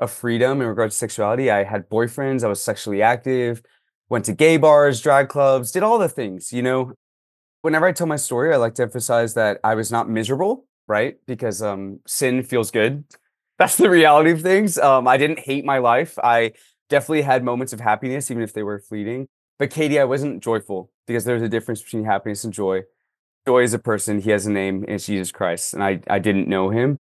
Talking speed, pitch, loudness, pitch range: 215 wpm, 120 Hz, -19 LUFS, 105-135 Hz